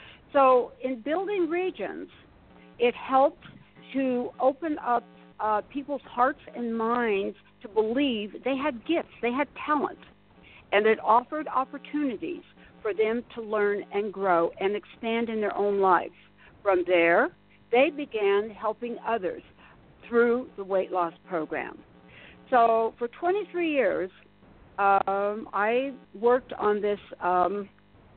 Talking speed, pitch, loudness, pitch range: 125 wpm, 230 Hz, -27 LUFS, 200-270 Hz